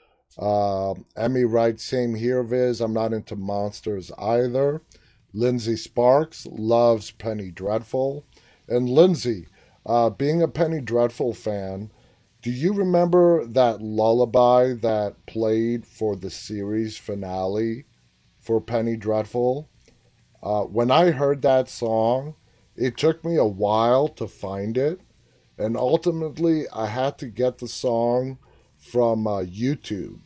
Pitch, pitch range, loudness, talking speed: 115 Hz, 110-130 Hz, -23 LUFS, 125 wpm